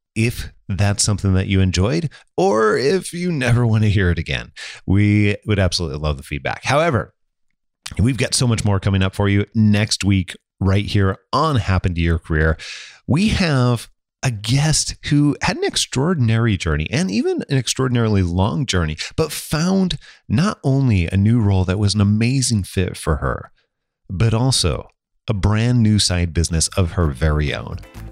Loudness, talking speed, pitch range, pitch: -18 LUFS, 170 wpm, 90-120 Hz, 100 Hz